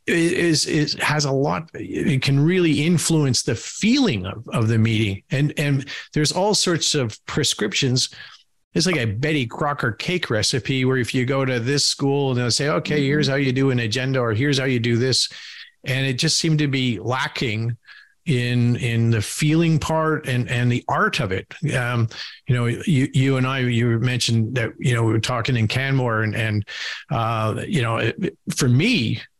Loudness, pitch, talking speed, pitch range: -20 LUFS, 130 Hz, 195 wpm, 120-150 Hz